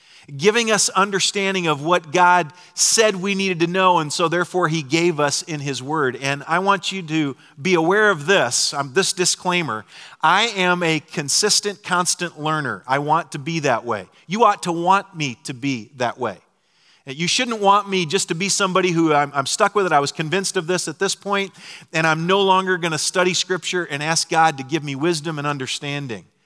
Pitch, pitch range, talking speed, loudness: 175 Hz, 150-190 Hz, 210 wpm, -19 LUFS